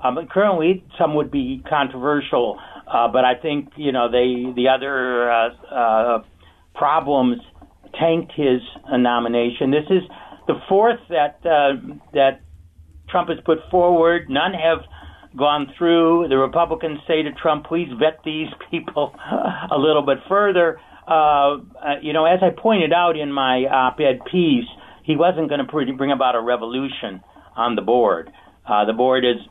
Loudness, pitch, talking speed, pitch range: -19 LUFS, 145 Hz, 155 wpm, 125-170 Hz